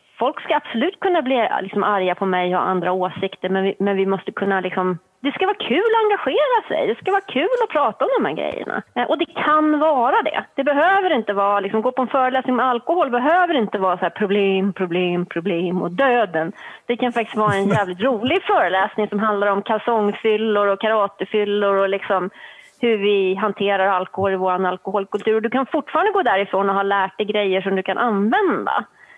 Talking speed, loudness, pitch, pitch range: 205 wpm, -19 LUFS, 210 Hz, 195-260 Hz